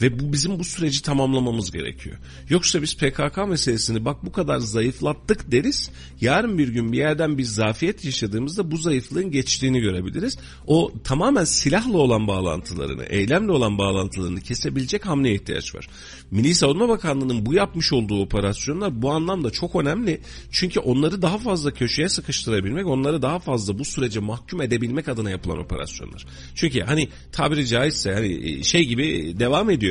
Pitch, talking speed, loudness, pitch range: 130 Hz, 155 wpm, -22 LUFS, 100-155 Hz